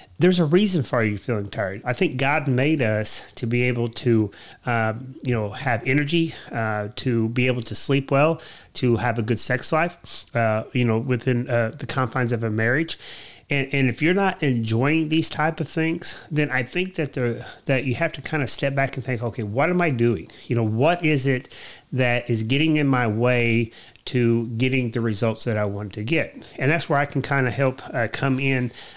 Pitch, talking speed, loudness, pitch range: 125 Hz, 215 wpm, -23 LUFS, 115-145 Hz